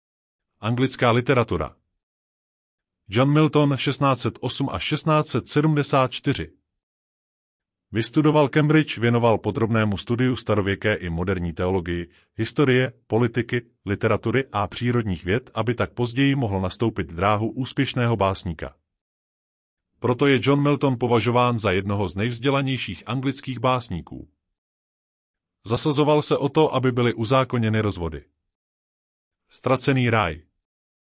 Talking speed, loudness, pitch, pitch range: 100 wpm, -22 LUFS, 115 Hz, 95-130 Hz